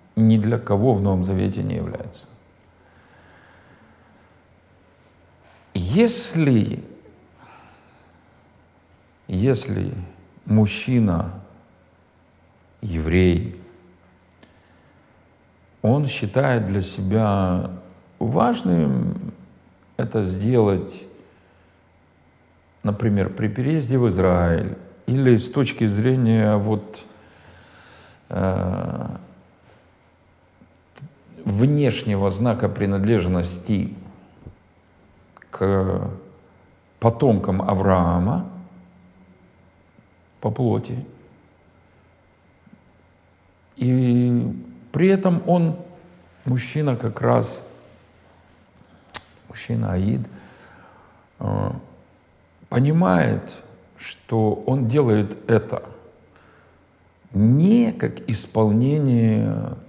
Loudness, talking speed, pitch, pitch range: -21 LUFS, 55 wpm, 100 Hz, 90-115 Hz